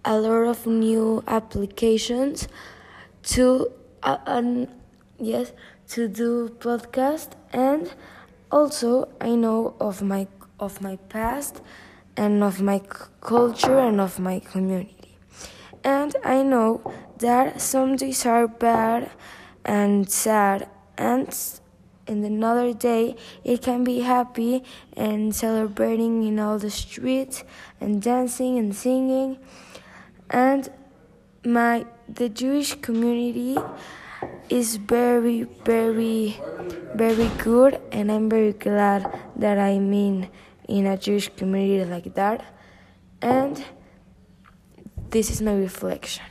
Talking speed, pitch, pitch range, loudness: 110 wpm, 230 Hz, 210-250 Hz, -23 LUFS